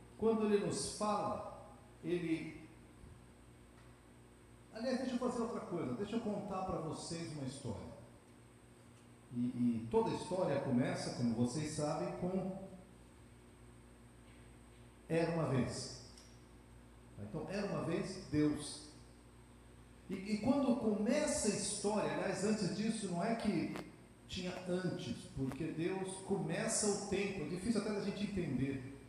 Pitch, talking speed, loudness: 160 Hz, 125 wpm, -39 LUFS